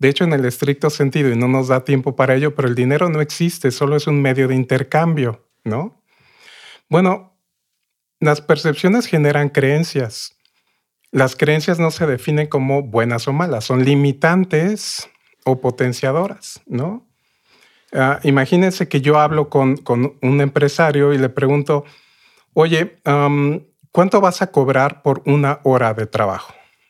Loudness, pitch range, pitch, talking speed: -17 LUFS, 130-160 Hz, 145 Hz, 150 wpm